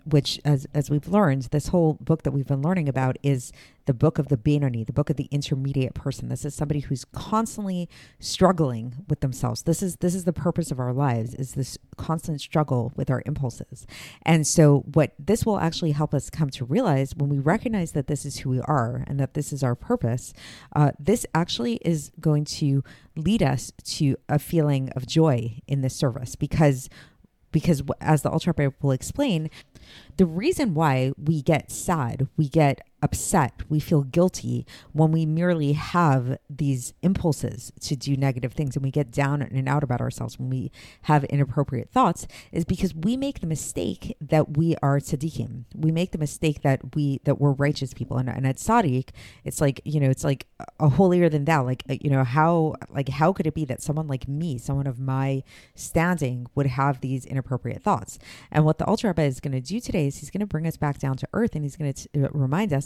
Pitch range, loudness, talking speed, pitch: 135-160 Hz, -24 LUFS, 205 wpm, 145 Hz